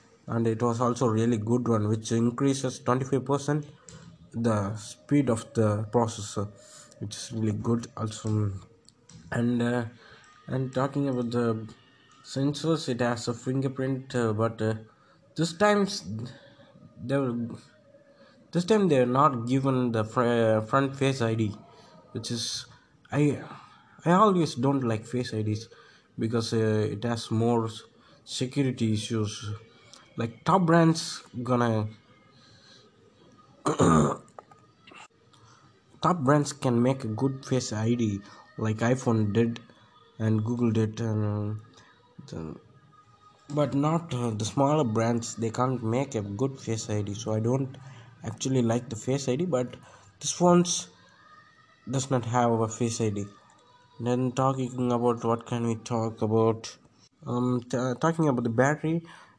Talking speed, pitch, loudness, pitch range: 130 wpm, 120 Hz, -27 LUFS, 115-135 Hz